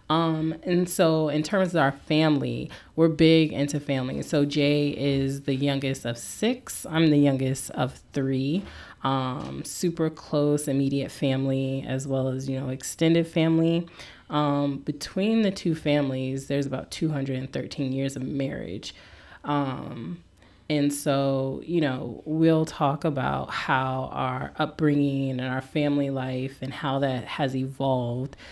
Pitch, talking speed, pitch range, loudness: 140 Hz, 140 wpm, 135-155 Hz, -26 LUFS